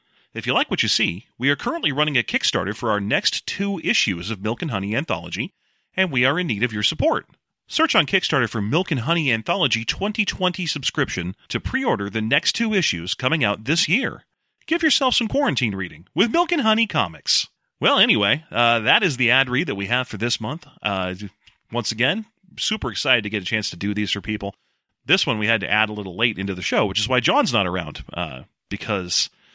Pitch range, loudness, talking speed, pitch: 105-175 Hz, -21 LUFS, 220 wpm, 125 Hz